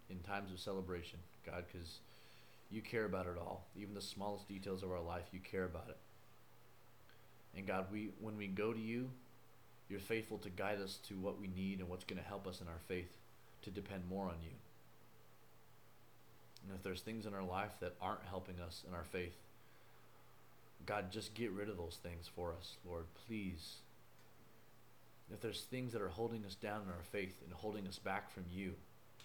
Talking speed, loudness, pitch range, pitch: 195 wpm, -47 LUFS, 90-110 Hz, 100 Hz